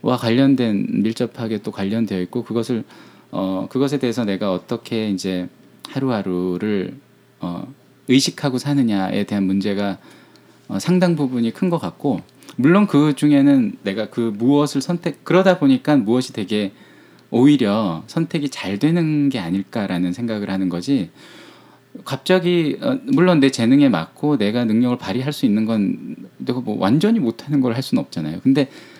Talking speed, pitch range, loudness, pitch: 310 characters per minute, 105-150 Hz, -19 LUFS, 125 Hz